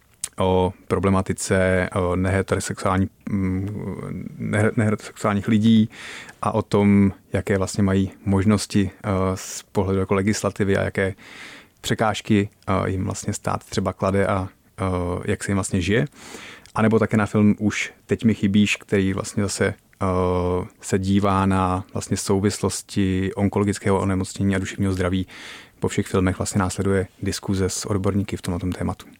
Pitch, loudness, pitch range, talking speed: 100 Hz, -22 LUFS, 95-105 Hz, 130 wpm